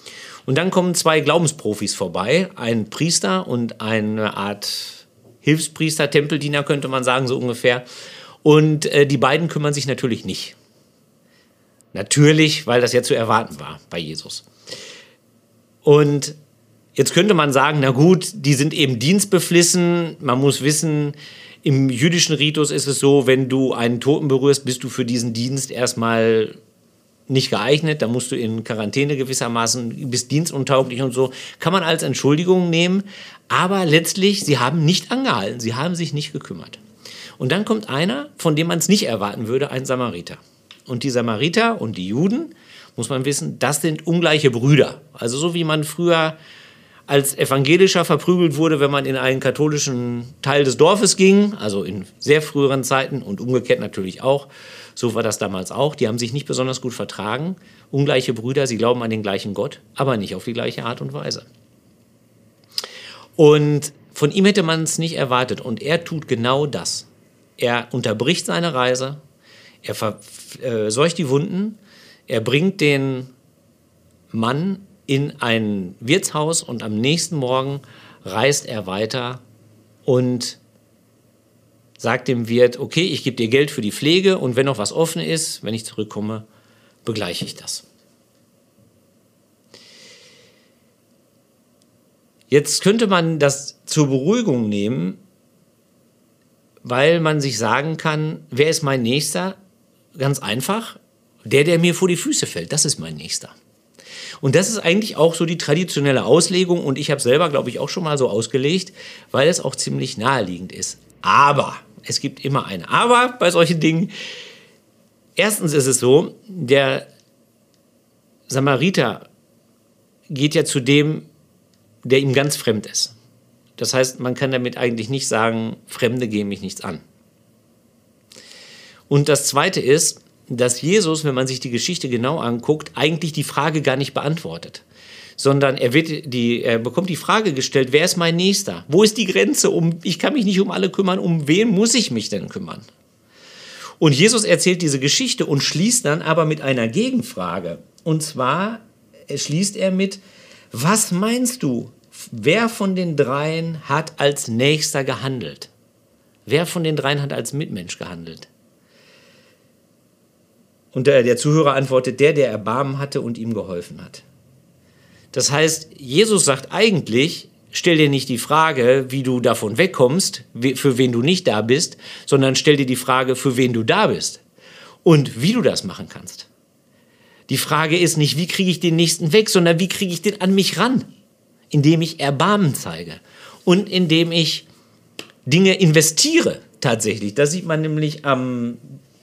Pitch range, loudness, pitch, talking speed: 125-170 Hz, -18 LUFS, 145 Hz, 155 wpm